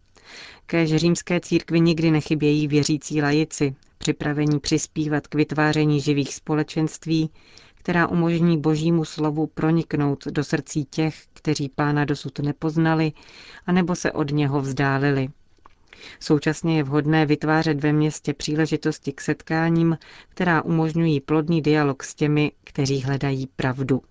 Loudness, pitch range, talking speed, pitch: -22 LUFS, 145-160 Hz, 120 wpm, 155 Hz